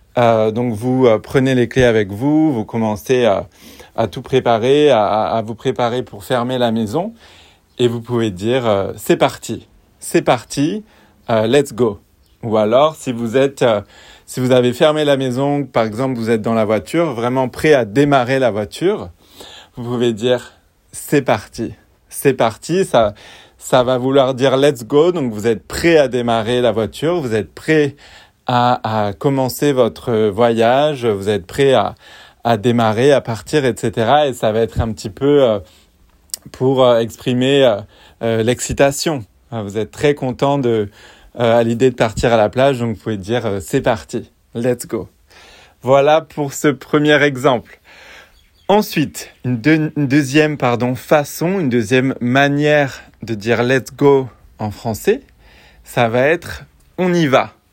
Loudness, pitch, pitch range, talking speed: -16 LUFS, 125 Hz, 110-140 Hz, 160 wpm